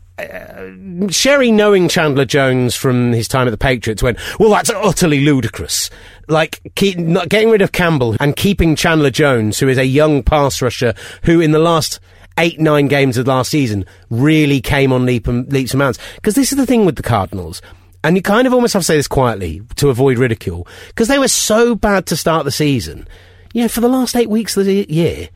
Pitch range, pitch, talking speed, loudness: 120-185 Hz, 140 Hz, 220 wpm, -14 LUFS